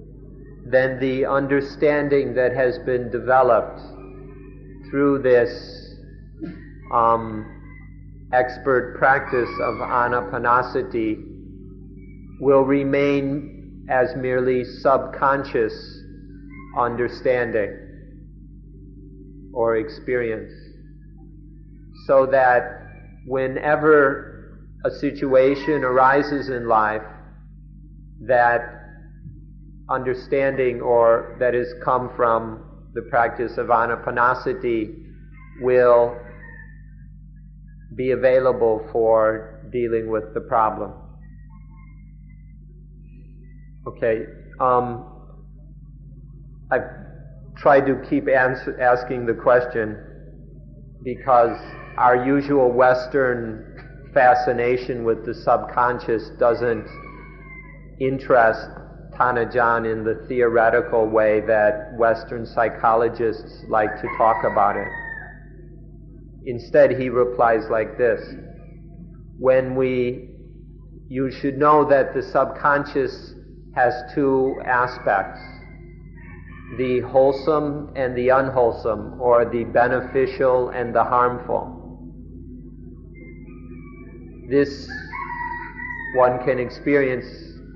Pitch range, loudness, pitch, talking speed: 115-140 Hz, -20 LUFS, 125 Hz, 75 wpm